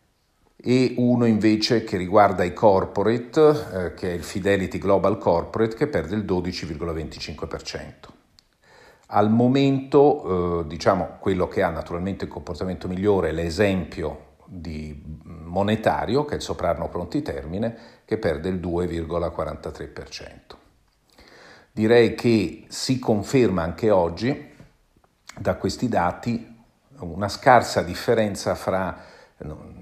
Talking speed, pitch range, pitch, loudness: 115 wpm, 85-115 Hz, 100 Hz, -22 LUFS